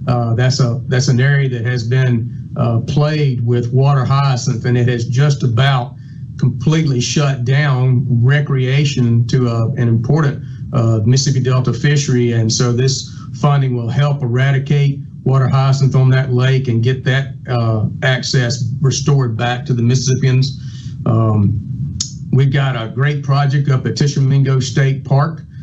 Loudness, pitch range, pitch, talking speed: -15 LUFS, 125-140 Hz, 130 Hz, 150 wpm